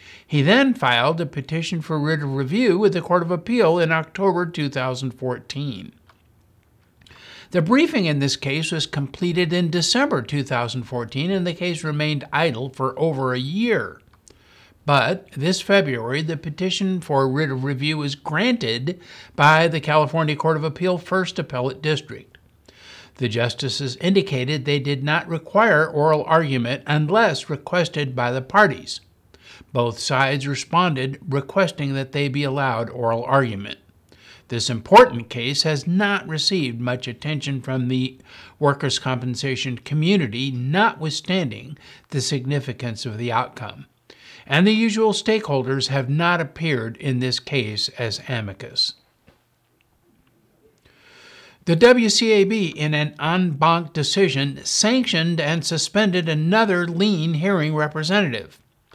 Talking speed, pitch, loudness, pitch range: 125 wpm, 150 Hz, -20 LUFS, 130-175 Hz